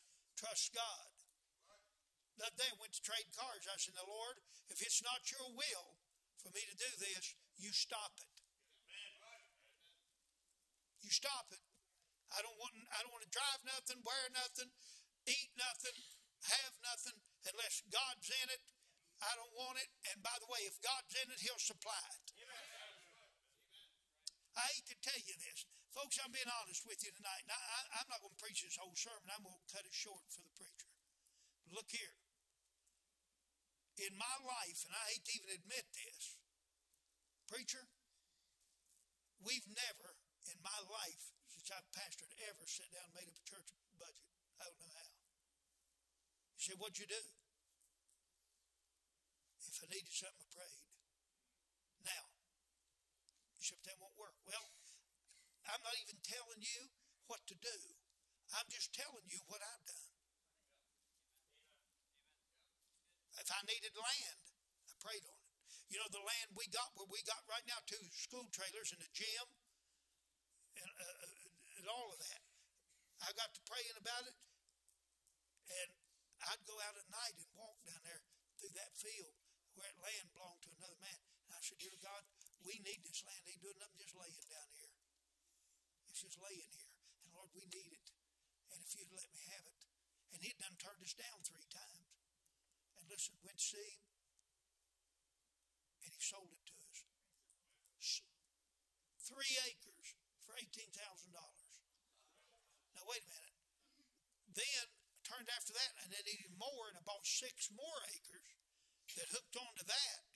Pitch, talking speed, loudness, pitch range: 200 Hz, 160 wpm, -46 LUFS, 165-235 Hz